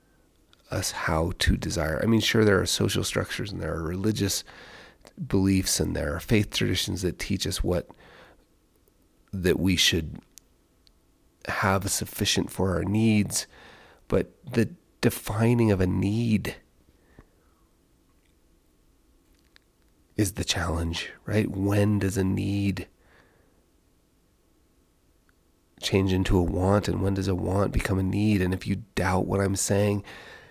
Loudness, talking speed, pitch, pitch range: -26 LUFS, 130 wpm, 95 Hz, 85-100 Hz